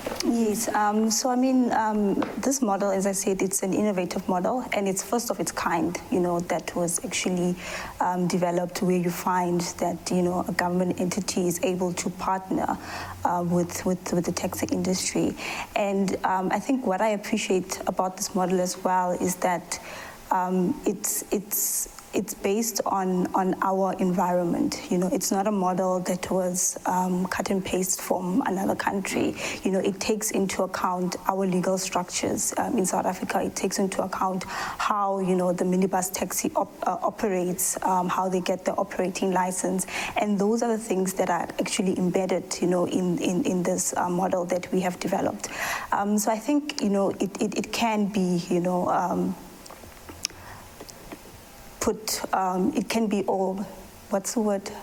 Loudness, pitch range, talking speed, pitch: -26 LUFS, 180-205 Hz, 180 wpm, 190 Hz